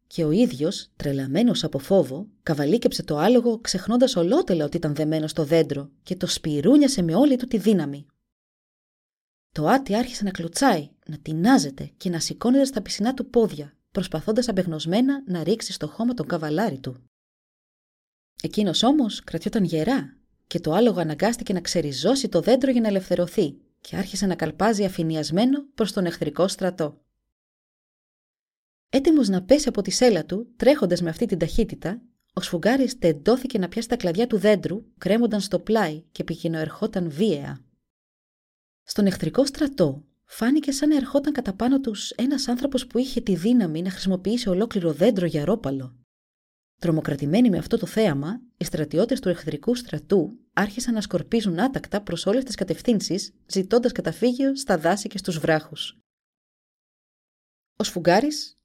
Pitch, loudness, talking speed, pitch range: 195 Hz, -23 LUFS, 150 wpm, 165-235 Hz